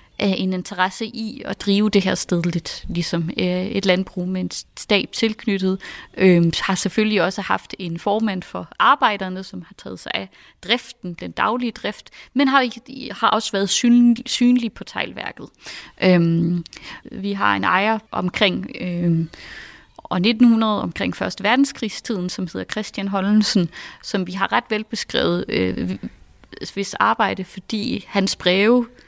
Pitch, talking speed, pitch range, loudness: 200 Hz, 145 wpm, 180-225 Hz, -20 LUFS